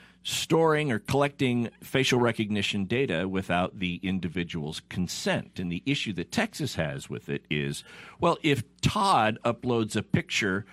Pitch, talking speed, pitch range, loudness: 105 Hz, 140 wpm, 90-135 Hz, -28 LUFS